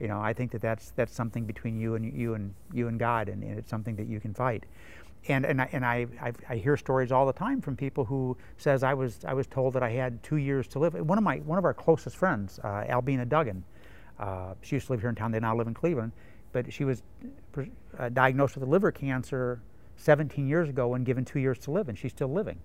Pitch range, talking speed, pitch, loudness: 110-135 Hz, 255 wpm, 125 Hz, -30 LUFS